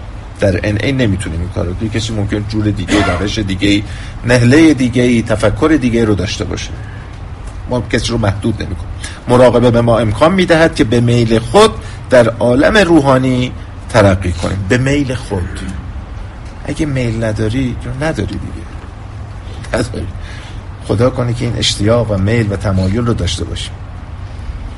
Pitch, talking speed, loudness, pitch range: 105 Hz, 150 wpm, -13 LUFS, 95-120 Hz